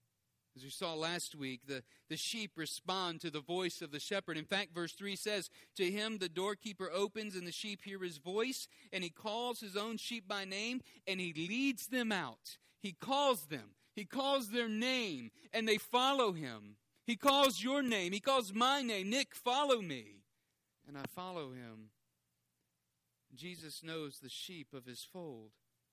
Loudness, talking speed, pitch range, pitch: -38 LUFS, 180 wpm, 145-225 Hz, 185 Hz